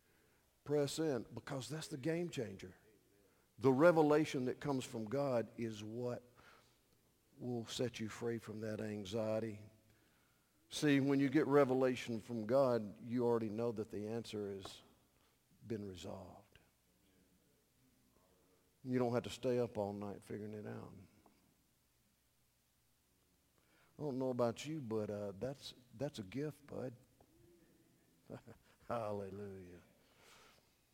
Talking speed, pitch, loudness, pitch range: 120 wpm, 115 Hz, -39 LUFS, 105-135 Hz